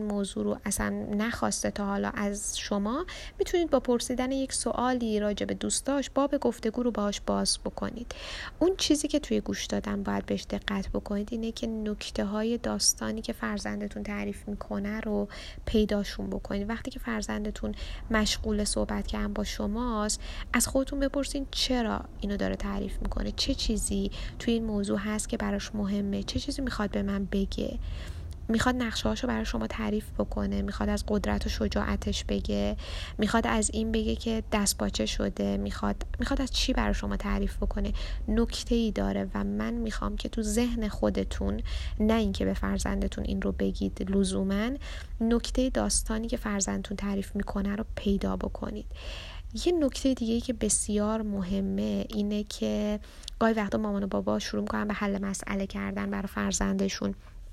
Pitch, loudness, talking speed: 200 Hz, -30 LUFS, 160 wpm